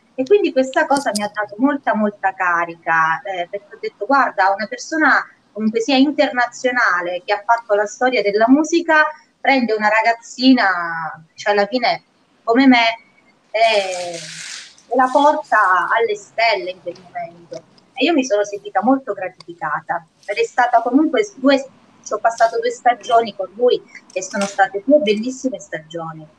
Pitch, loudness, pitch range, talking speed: 230 Hz, -17 LUFS, 195-265 Hz, 155 wpm